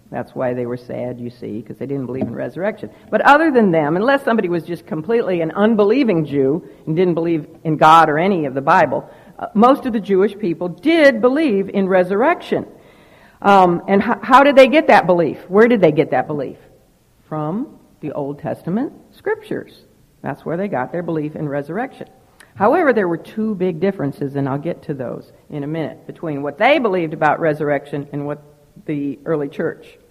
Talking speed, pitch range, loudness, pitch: 195 wpm, 145-215 Hz, -17 LUFS, 170 Hz